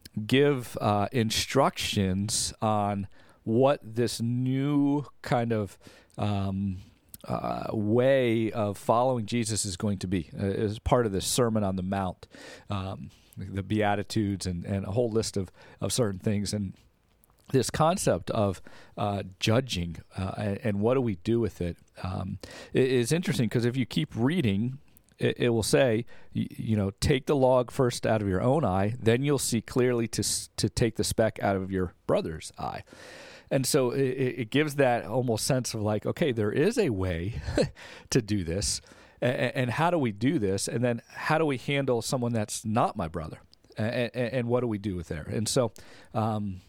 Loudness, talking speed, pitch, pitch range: -28 LUFS, 175 wpm, 110 Hz, 100-125 Hz